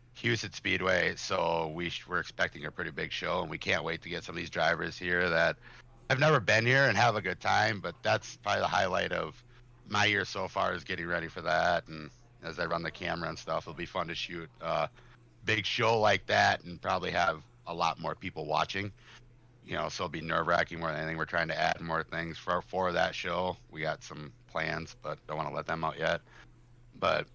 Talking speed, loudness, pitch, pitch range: 230 wpm, -31 LUFS, 90 Hz, 80-115 Hz